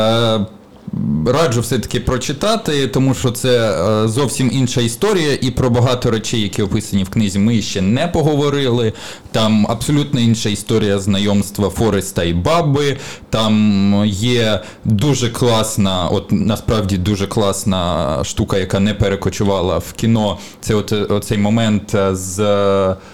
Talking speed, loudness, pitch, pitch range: 125 wpm, -16 LUFS, 110 Hz, 100-125 Hz